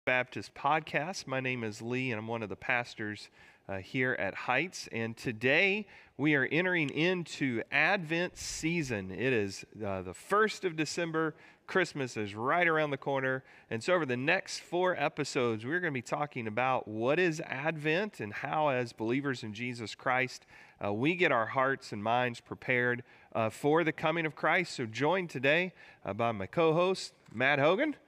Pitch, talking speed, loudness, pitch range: 135 Hz, 180 wpm, -31 LUFS, 115-160 Hz